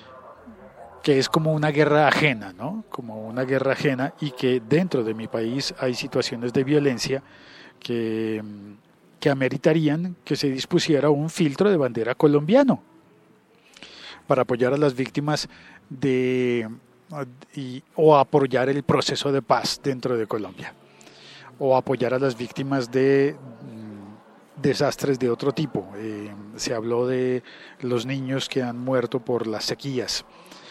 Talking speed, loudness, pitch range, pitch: 135 wpm, -23 LUFS, 120-145 Hz, 135 Hz